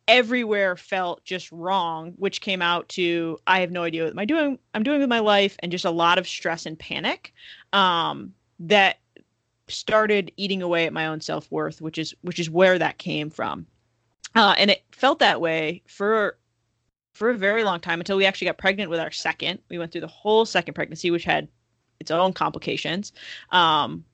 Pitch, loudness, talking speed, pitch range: 180 Hz, -23 LUFS, 195 wpm, 165-200 Hz